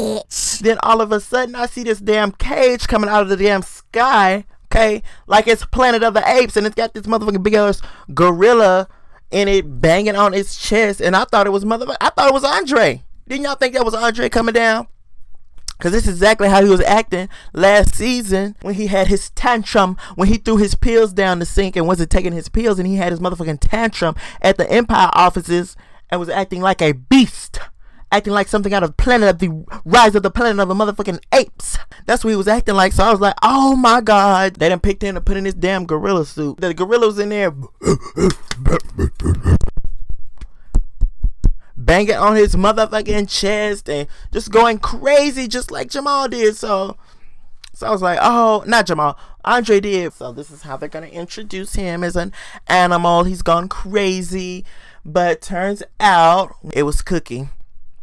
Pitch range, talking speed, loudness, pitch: 180-225 Hz, 195 wpm, -15 LUFS, 200 Hz